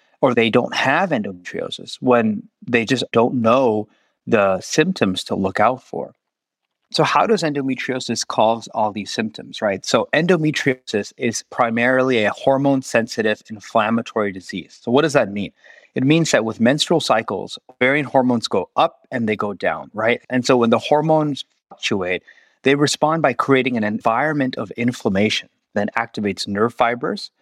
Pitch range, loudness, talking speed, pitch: 115-150 Hz, -19 LUFS, 160 wpm, 130 Hz